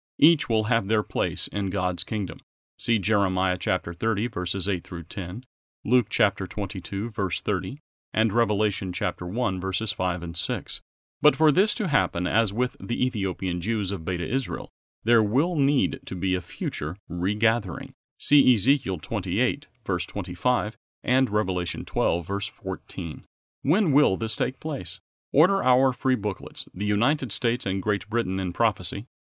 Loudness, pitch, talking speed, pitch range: -25 LUFS, 105 Hz, 160 wpm, 95-120 Hz